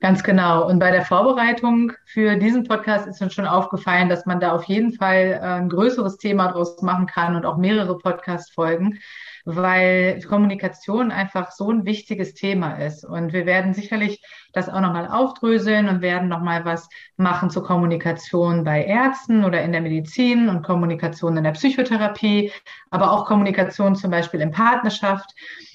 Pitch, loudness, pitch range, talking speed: 185 Hz, -20 LUFS, 175-210 Hz, 165 wpm